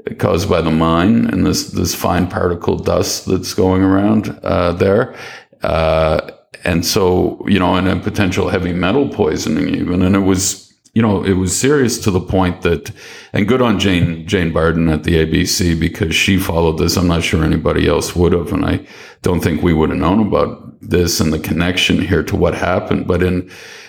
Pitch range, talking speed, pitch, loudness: 85-95 Hz, 195 wpm, 90 Hz, -15 LUFS